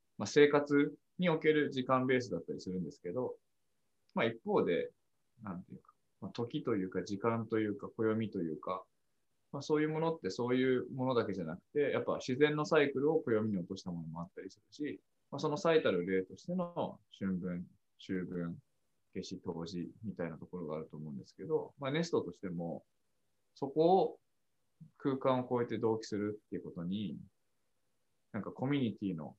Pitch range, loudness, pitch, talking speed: 95-150 Hz, -36 LUFS, 120 Hz, 365 characters per minute